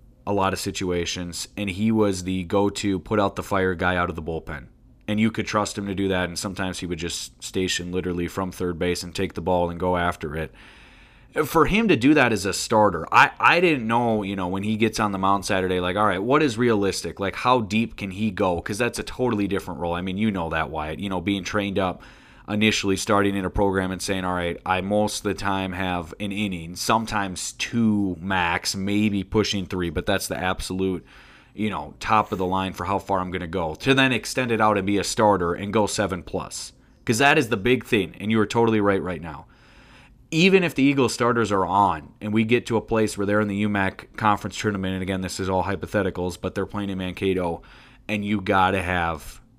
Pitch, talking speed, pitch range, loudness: 100 Hz, 235 wpm, 90-110 Hz, -23 LUFS